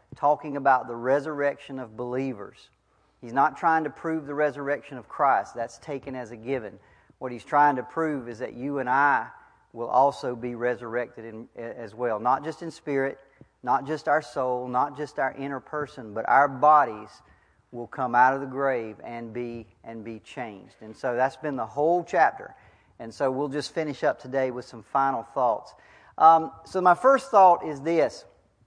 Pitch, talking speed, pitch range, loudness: 135 Hz, 180 wpm, 120-150 Hz, -25 LUFS